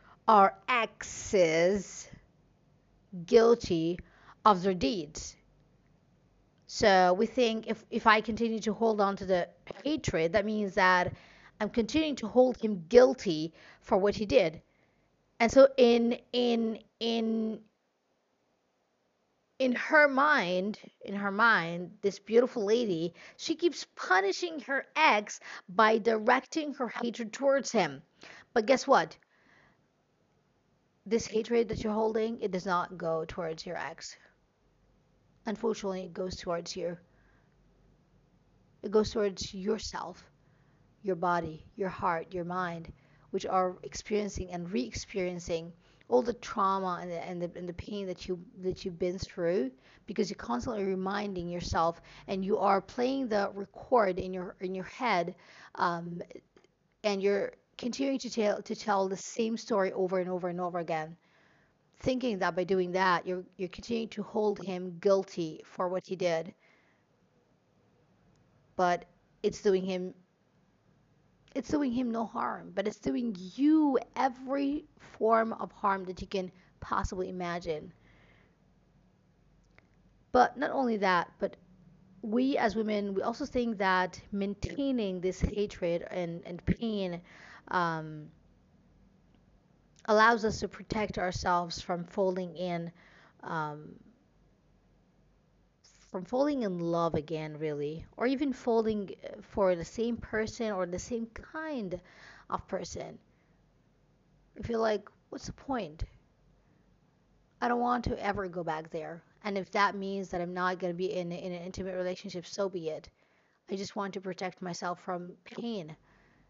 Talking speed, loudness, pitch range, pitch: 135 wpm, -31 LUFS, 180-225 Hz, 195 Hz